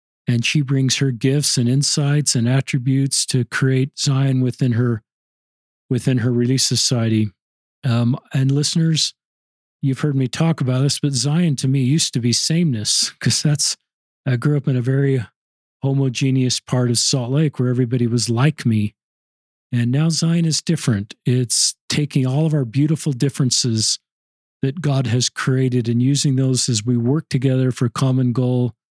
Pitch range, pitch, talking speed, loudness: 125-145 Hz, 130 Hz, 165 wpm, -18 LUFS